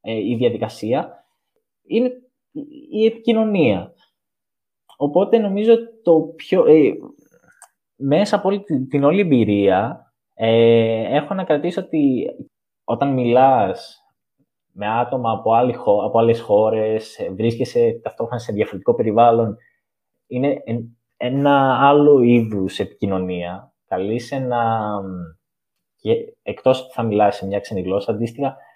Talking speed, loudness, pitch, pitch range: 105 wpm, -18 LUFS, 130 Hz, 115-185 Hz